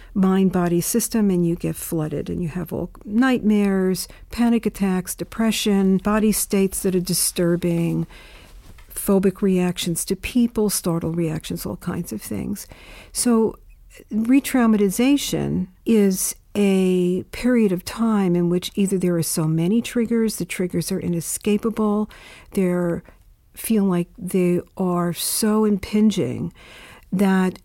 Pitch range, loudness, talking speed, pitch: 175-215 Hz, -21 LUFS, 125 wpm, 190 Hz